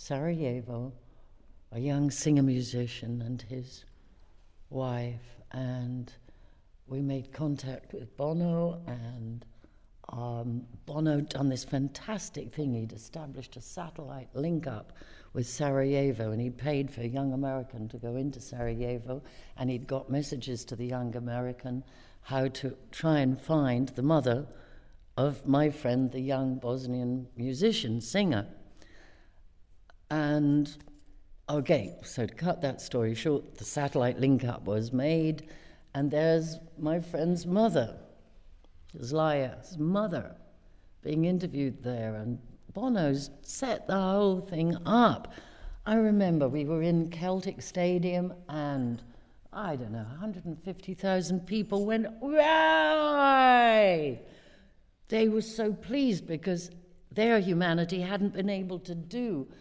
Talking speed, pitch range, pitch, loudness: 120 wpm, 120-170 Hz, 140 Hz, -30 LUFS